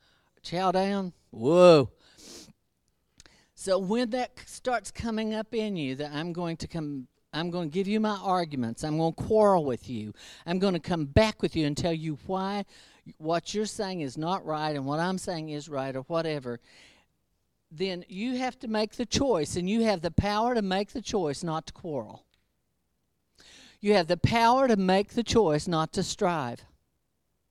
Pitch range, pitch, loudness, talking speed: 155-210 Hz, 180 Hz, -28 LUFS, 185 wpm